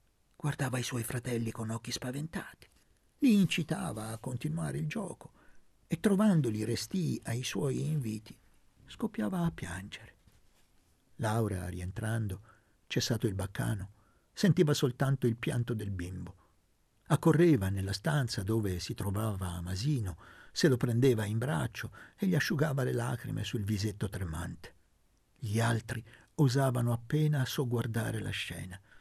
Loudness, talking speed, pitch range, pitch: -33 LUFS, 125 wpm, 105-145 Hz, 115 Hz